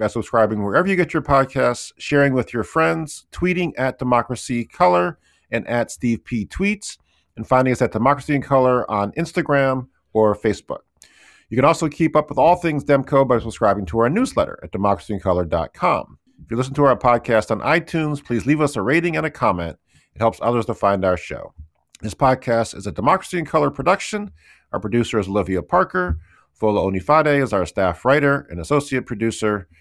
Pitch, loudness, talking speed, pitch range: 125 Hz, -19 LUFS, 185 wpm, 105-145 Hz